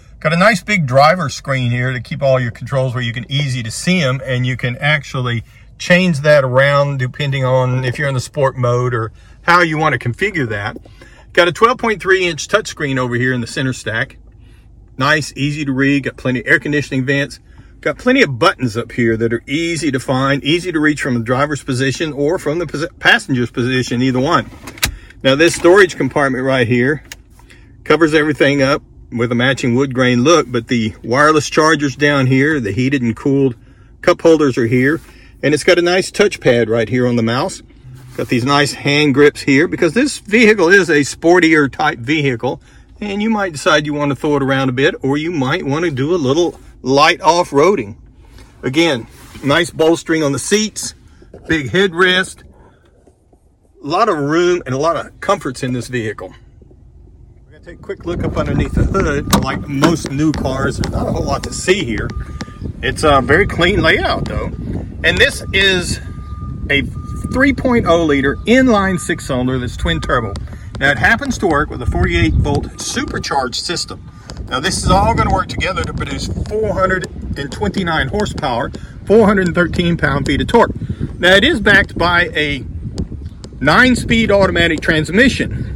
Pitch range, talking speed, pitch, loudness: 125-165 Hz, 185 wpm, 140 Hz, -14 LUFS